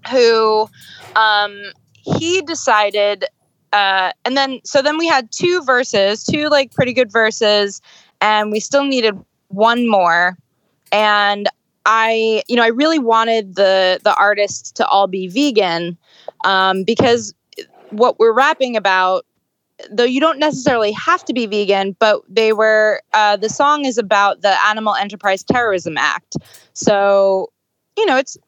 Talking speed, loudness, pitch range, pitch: 145 wpm, -15 LUFS, 200-255 Hz, 215 Hz